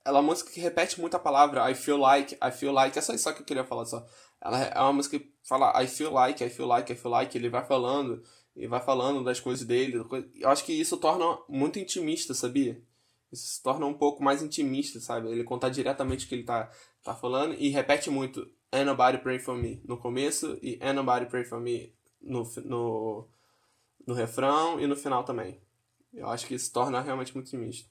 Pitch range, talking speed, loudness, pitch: 120-145 Hz, 225 wpm, -29 LUFS, 130 Hz